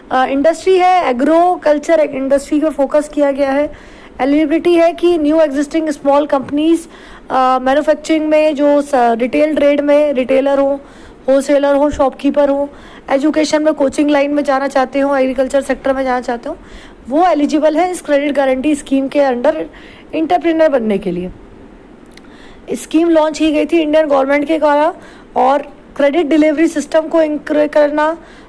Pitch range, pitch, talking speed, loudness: 275-310 Hz, 290 Hz, 155 wpm, -13 LUFS